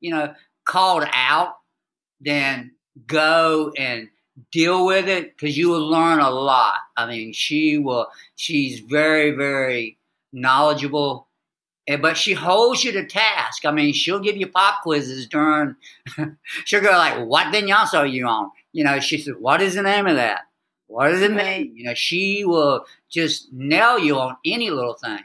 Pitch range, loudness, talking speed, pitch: 140-185 Hz, -19 LUFS, 170 wpm, 150 Hz